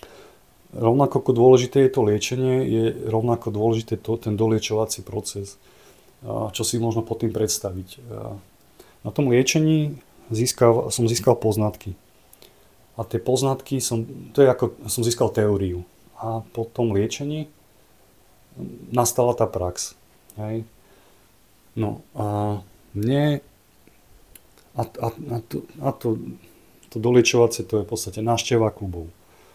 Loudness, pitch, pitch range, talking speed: -22 LUFS, 115 Hz, 105-125 Hz, 120 wpm